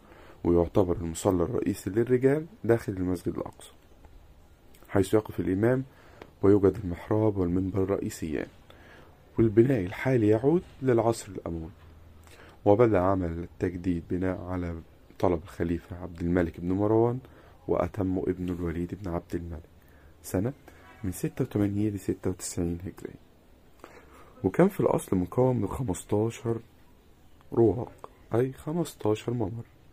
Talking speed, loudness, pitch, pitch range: 105 wpm, -28 LUFS, 95 Hz, 85-110 Hz